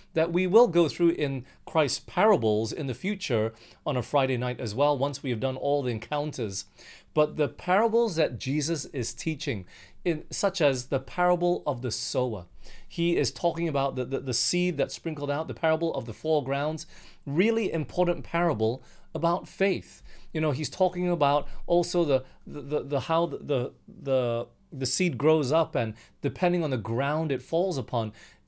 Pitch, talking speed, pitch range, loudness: 145 Hz, 180 wpm, 125-170 Hz, -27 LUFS